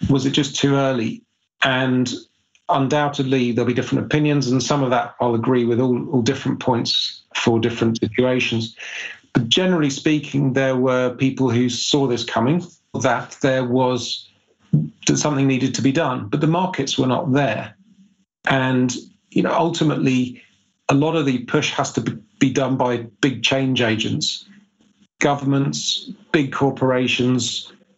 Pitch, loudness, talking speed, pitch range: 135 Hz, -20 LUFS, 150 wpm, 125-145 Hz